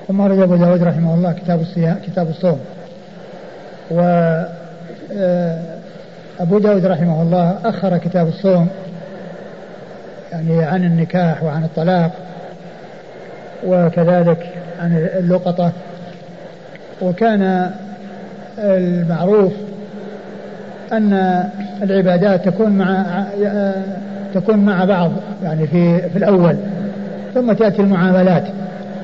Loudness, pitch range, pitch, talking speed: -16 LUFS, 175-195 Hz, 185 Hz, 85 wpm